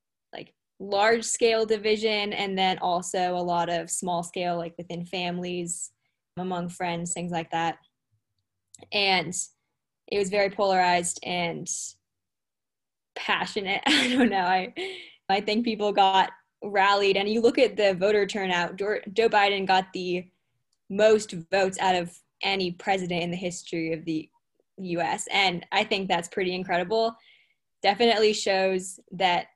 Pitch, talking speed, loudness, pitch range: 185 Hz, 130 wpm, -25 LUFS, 175-205 Hz